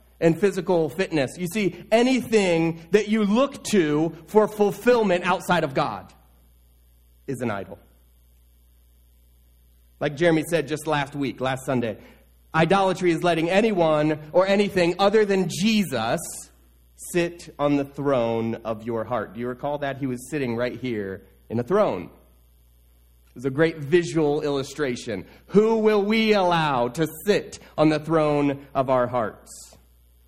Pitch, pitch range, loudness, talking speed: 150 Hz, 115-180 Hz, -23 LUFS, 145 wpm